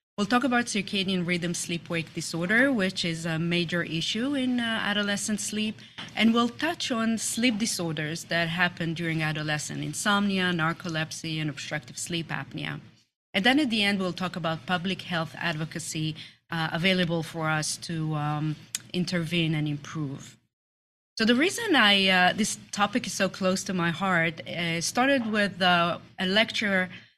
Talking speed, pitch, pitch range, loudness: 160 wpm, 175 Hz, 160-205 Hz, -26 LUFS